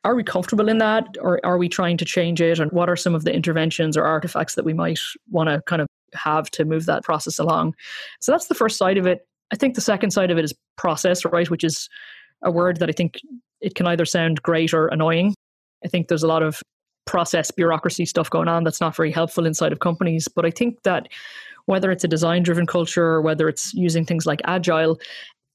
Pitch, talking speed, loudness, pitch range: 175 Hz, 235 wpm, -21 LUFS, 165-185 Hz